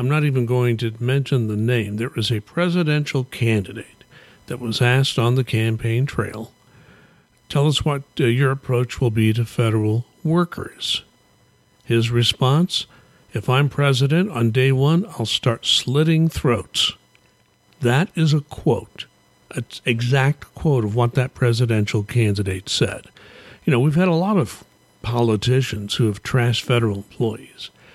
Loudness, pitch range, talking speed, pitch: -20 LUFS, 115-140 Hz, 150 wpm, 125 Hz